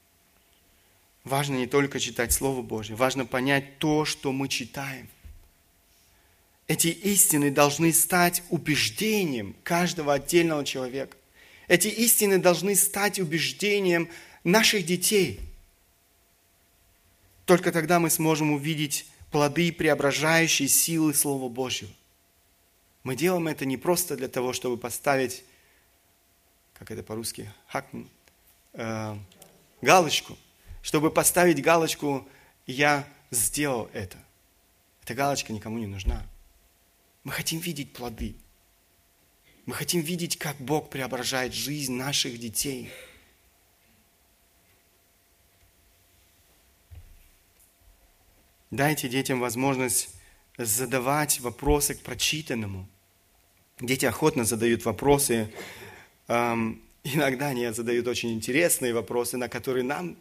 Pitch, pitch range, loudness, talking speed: 125 Hz, 95-150 Hz, -25 LUFS, 95 wpm